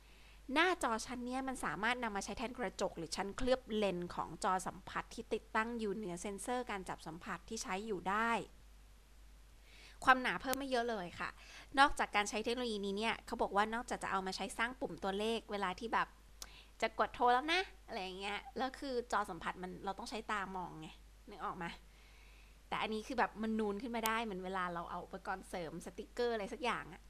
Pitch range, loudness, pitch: 190-235 Hz, -39 LUFS, 215 Hz